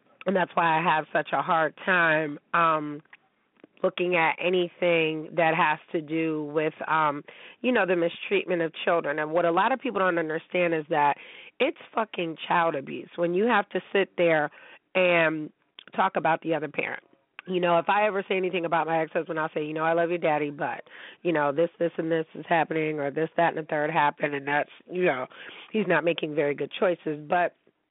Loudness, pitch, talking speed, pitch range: -26 LUFS, 165 Hz, 205 wpm, 155-180 Hz